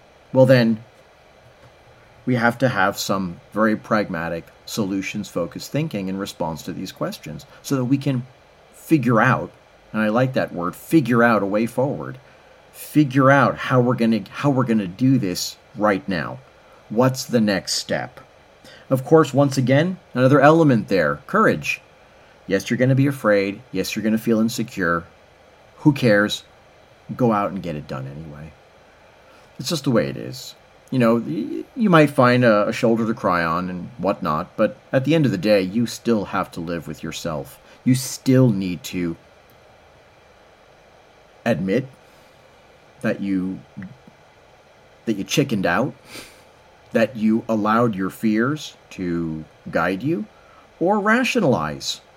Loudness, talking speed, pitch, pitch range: -20 LUFS, 155 wpm, 120 Hz, 100-135 Hz